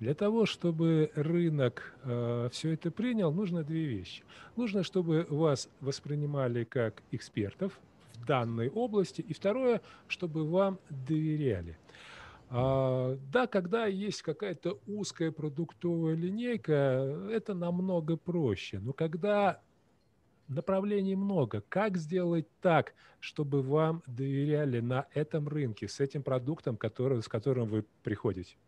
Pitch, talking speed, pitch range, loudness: 155 Hz, 120 wpm, 130-180 Hz, -33 LUFS